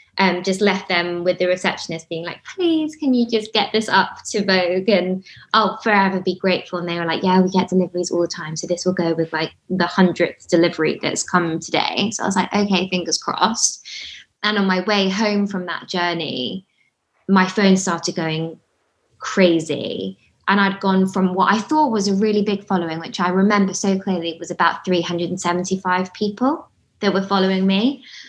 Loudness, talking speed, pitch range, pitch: -19 LUFS, 195 wpm, 175-200 Hz, 185 Hz